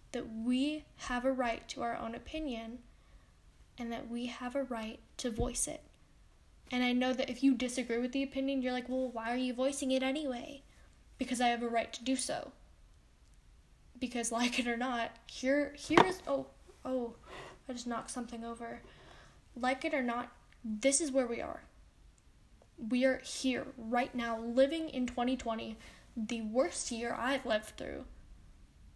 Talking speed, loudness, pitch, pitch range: 170 wpm, -35 LUFS, 250 Hz, 235-265 Hz